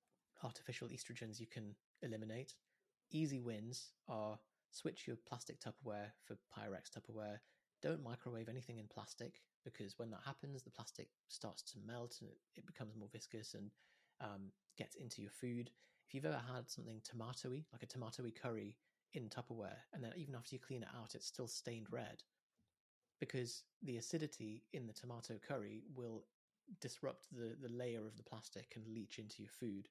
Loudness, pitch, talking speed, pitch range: -51 LUFS, 115 Hz, 170 wpm, 110-130 Hz